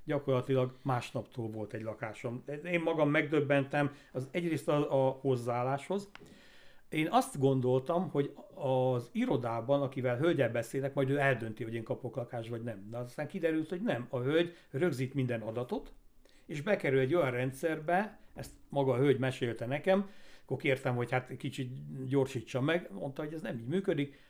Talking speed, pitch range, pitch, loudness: 160 wpm, 125-155 Hz, 135 Hz, -33 LUFS